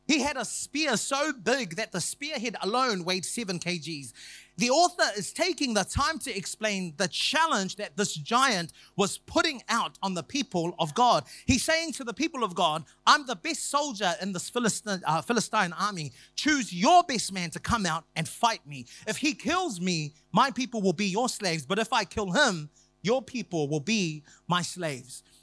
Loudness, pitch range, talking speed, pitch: -27 LUFS, 175-260 Hz, 195 wpm, 210 Hz